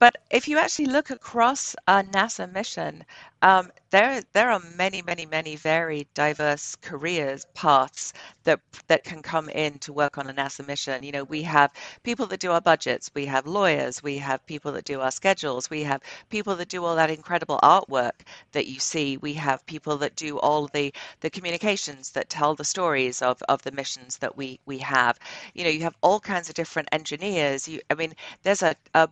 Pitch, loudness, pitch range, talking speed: 155 Hz, -25 LUFS, 140-180 Hz, 200 wpm